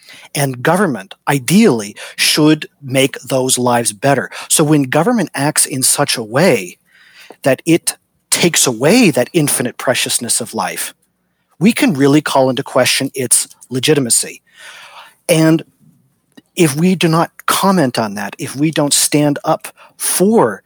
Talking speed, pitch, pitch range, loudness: 135 wpm, 145 Hz, 130-165 Hz, -13 LUFS